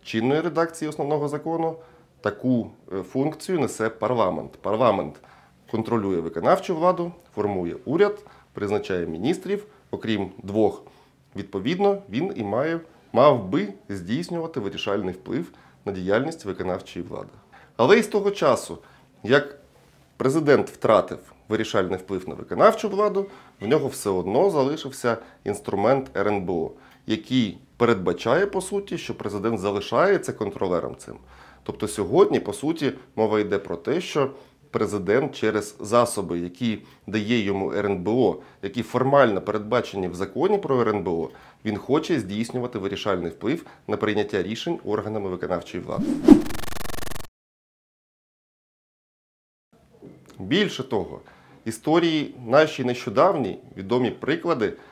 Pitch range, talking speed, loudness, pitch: 105-160 Hz, 110 wpm, -24 LUFS, 120 Hz